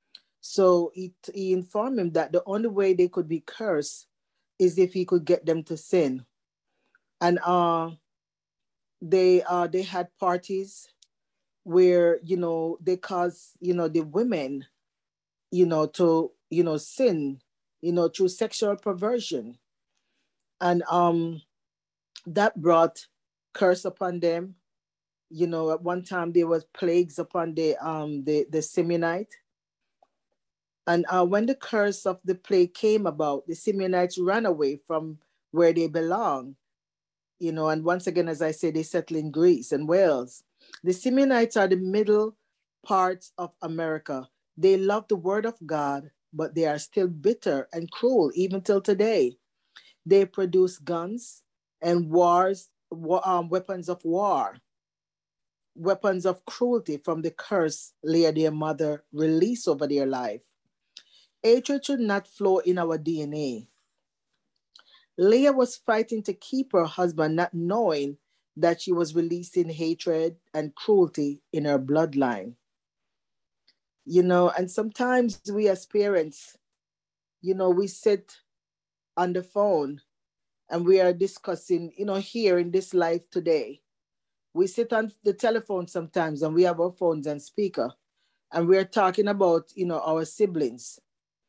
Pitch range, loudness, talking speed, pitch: 160-195 Hz, -25 LUFS, 145 wpm, 175 Hz